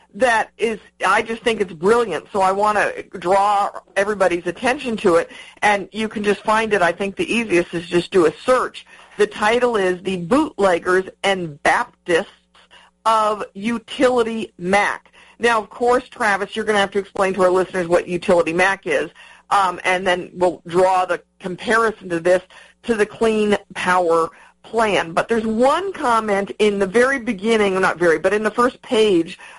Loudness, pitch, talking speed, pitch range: -19 LUFS, 200 Hz, 180 wpm, 185-225 Hz